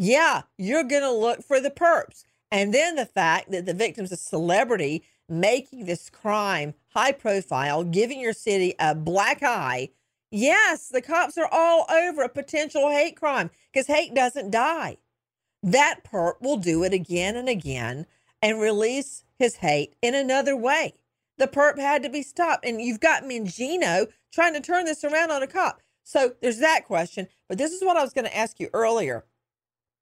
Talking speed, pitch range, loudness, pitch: 175 wpm, 190-290 Hz, -24 LUFS, 245 Hz